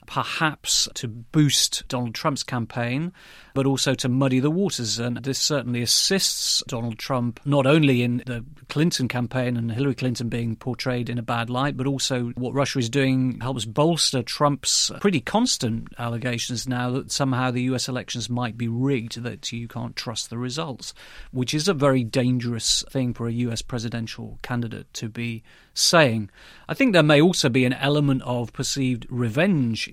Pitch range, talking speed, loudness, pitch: 120-140 Hz, 170 wpm, -23 LUFS, 125 Hz